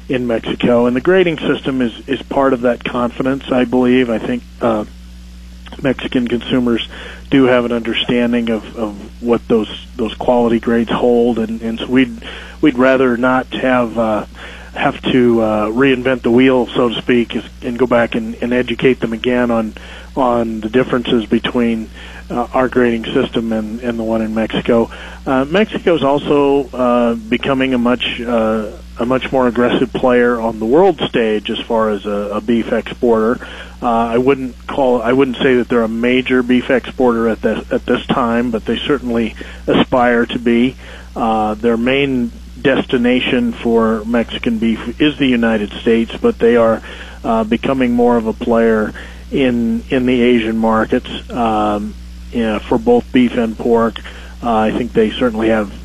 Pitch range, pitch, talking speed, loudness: 110-130 Hz, 120 Hz, 170 wpm, -15 LUFS